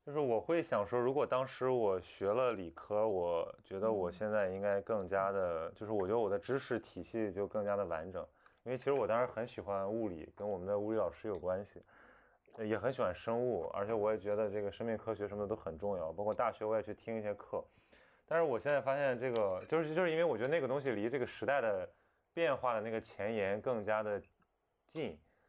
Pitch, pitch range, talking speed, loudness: 110 Hz, 100-125 Hz, 330 characters per minute, -37 LUFS